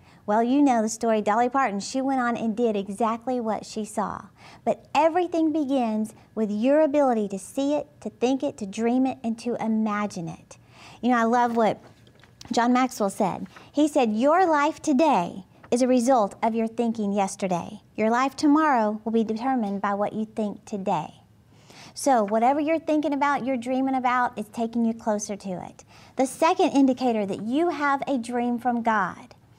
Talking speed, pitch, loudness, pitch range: 185 wpm, 235 Hz, -24 LUFS, 210-265 Hz